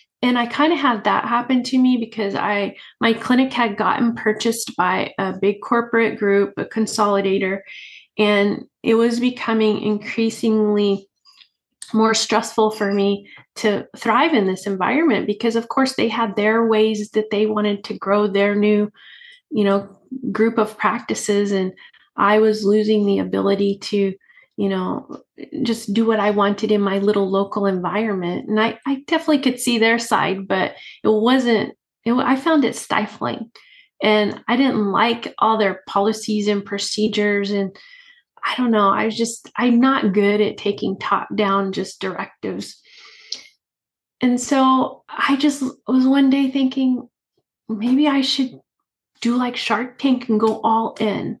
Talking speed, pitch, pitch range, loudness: 160 wpm, 220 Hz, 205-250 Hz, -19 LUFS